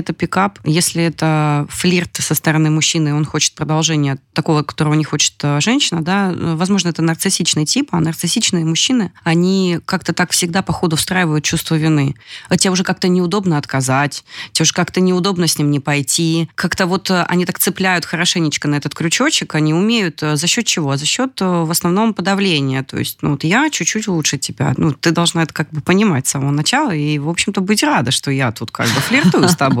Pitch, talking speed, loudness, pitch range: 165 Hz, 195 wpm, -15 LUFS, 150-185 Hz